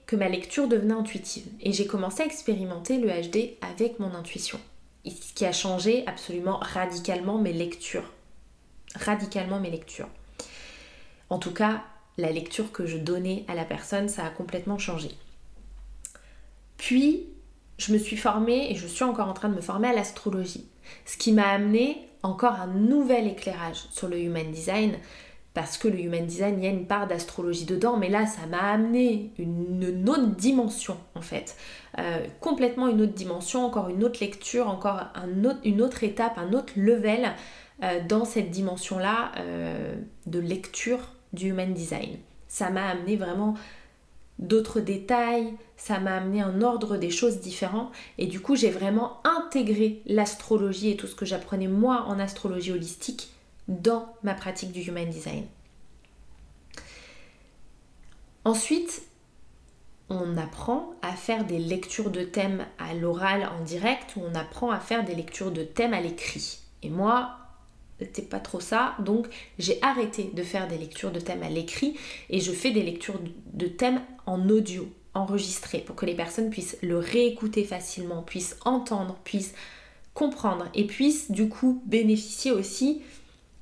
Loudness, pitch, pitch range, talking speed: -28 LUFS, 205 Hz, 180-230 Hz, 160 wpm